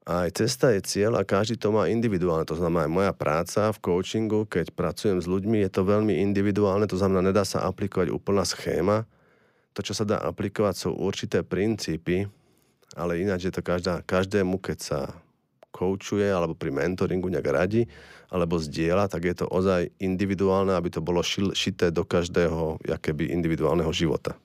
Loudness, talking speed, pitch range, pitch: -26 LUFS, 170 wpm, 85-100 Hz, 95 Hz